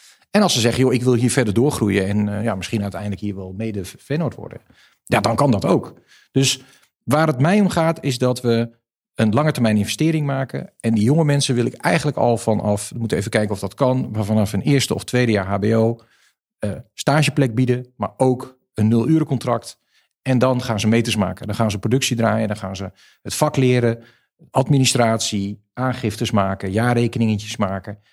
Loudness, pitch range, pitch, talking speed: -19 LUFS, 105-130 Hz, 115 Hz, 200 wpm